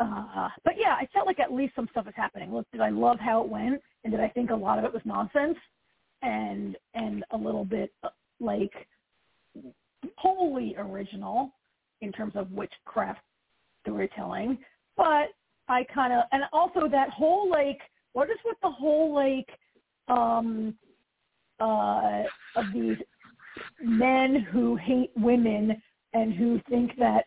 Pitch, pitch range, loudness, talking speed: 240 Hz, 220-285 Hz, -28 LUFS, 150 wpm